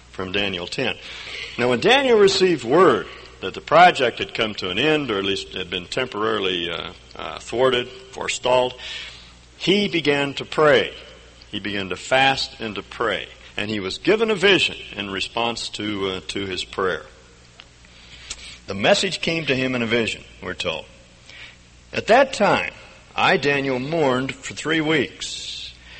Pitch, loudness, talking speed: 110 Hz, -21 LUFS, 160 wpm